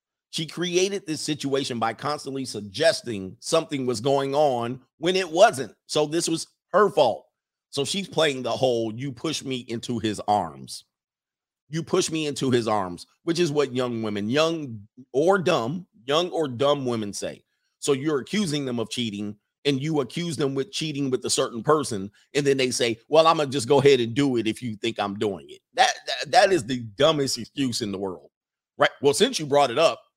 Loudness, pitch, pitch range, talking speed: -24 LUFS, 140 Hz, 115-160 Hz, 200 wpm